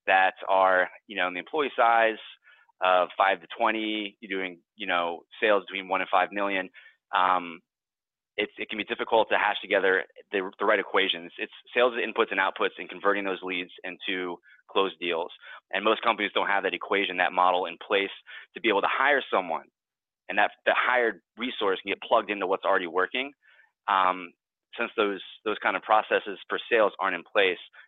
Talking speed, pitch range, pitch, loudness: 190 wpm, 90-110 Hz, 95 Hz, -26 LUFS